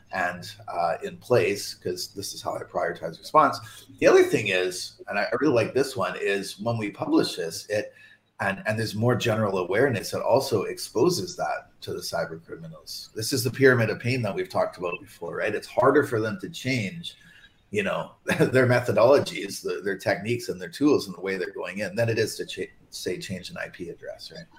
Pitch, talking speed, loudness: 125 Hz, 210 wpm, -25 LUFS